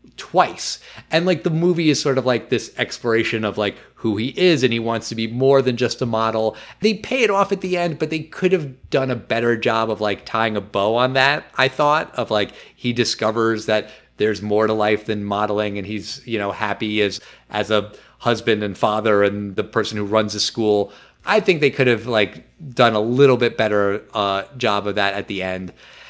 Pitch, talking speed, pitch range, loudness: 115 Hz, 225 wpm, 105-135 Hz, -20 LUFS